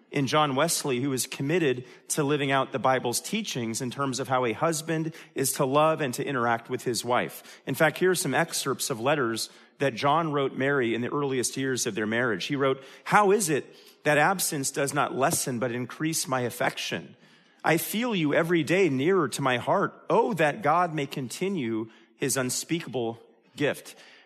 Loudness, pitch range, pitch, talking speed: -26 LUFS, 130-160 Hz, 140 Hz, 190 wpm